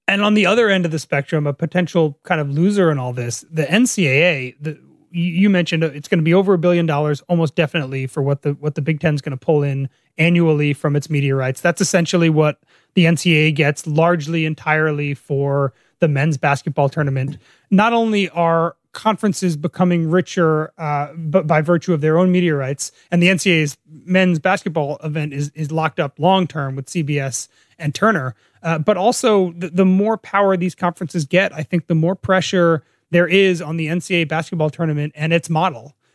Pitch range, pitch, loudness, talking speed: 150-180 Hz, 165 Hz, -18 LUFS, 190 wpm